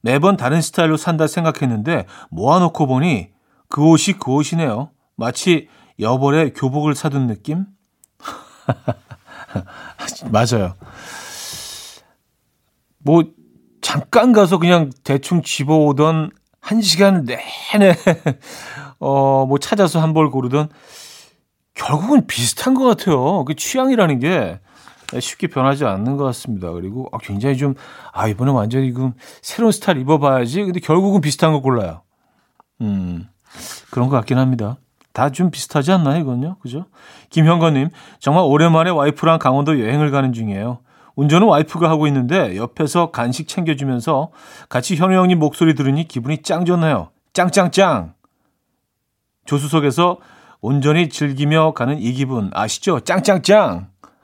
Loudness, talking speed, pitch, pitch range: -16 LUFS, 280 characters per minute, 150 Hz, 130-175 Hz